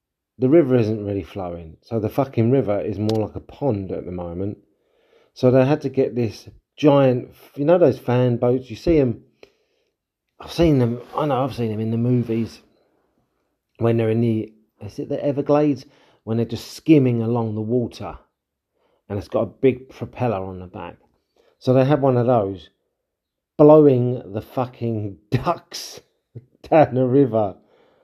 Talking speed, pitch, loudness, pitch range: 170 wpm, 120 Hz, -20 LUFS, 110-140 Hz